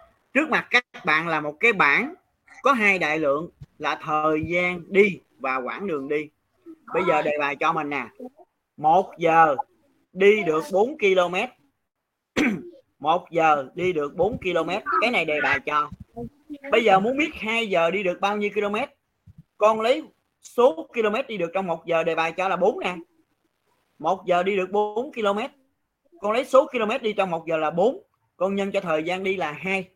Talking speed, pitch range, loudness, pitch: 190 wpm, 160-235 Hz, -23 LUFS, 190 Hz